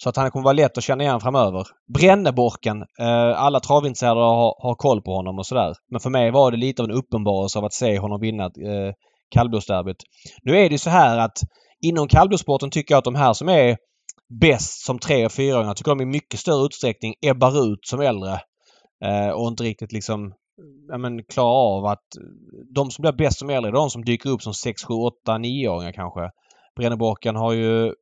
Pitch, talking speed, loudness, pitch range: 120 Hz, 210 wpm, -20 LUFS, 105-135 Hz